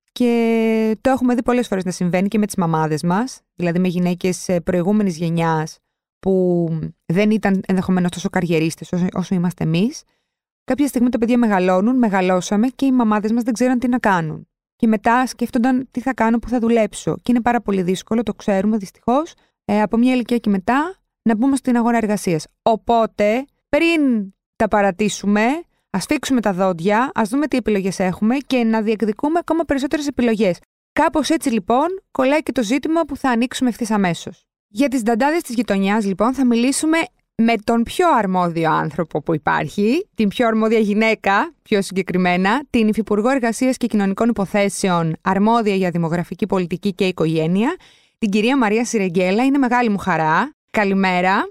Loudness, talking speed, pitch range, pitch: -18 LUFS, 165 wpm, 190-250 Hz, 220 Hz